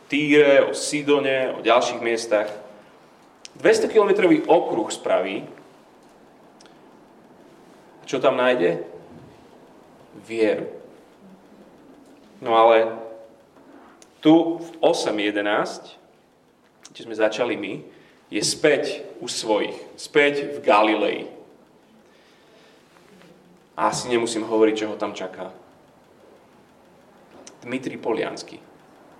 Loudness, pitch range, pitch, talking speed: -21 LUFS, 110-170 Hz, 125 Hz, 85 wpm